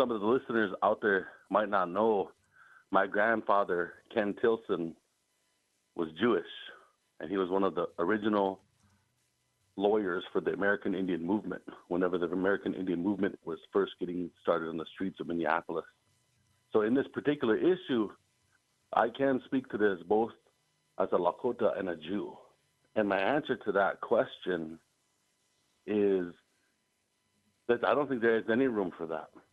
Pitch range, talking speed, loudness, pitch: 90-125 Hz, 155 wpm, -31 LUFS, 100 Hz